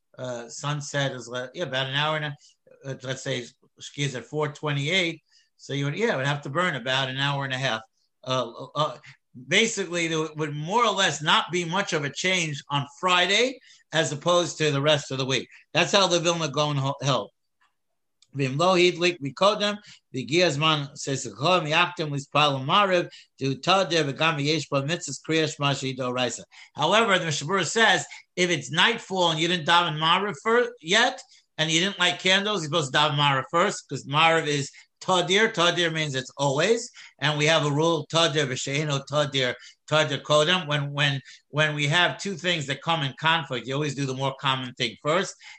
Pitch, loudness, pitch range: 155 Hz, -24 LUFS, 140-175 Hz